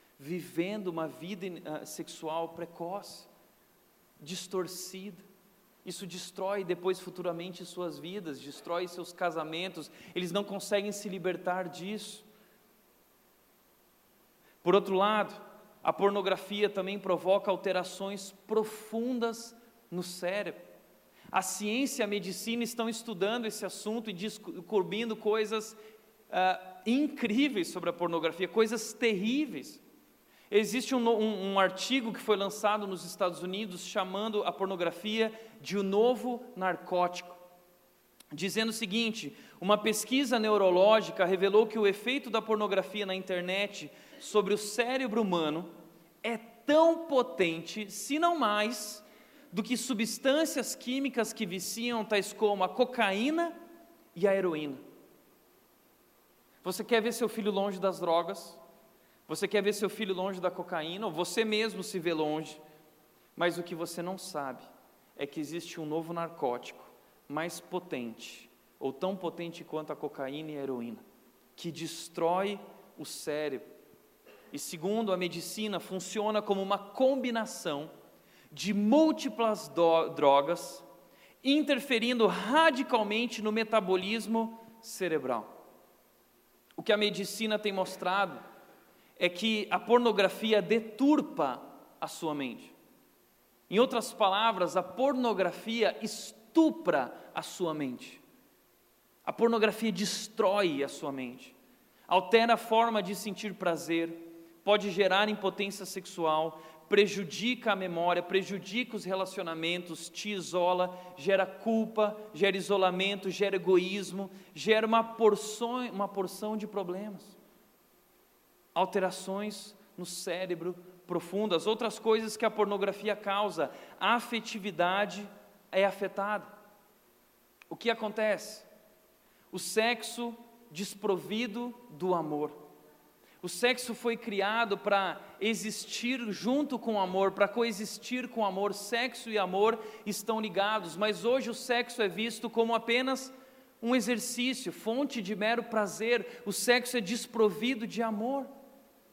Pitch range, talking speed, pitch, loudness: 180-225 Hz, 120 wpm, 205 Hz, -31 LUFS